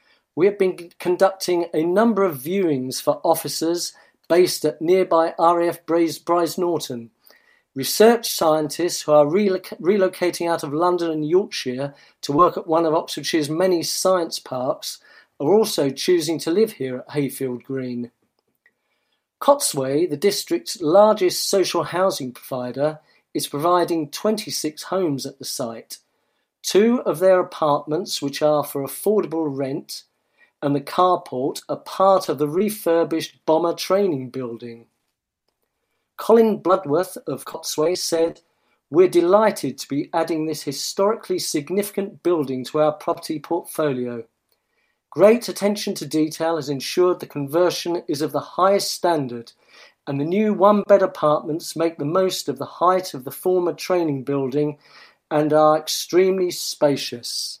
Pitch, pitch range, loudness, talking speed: 165 Hz, 145-185 Hz, -21 LUFS, 135 wpm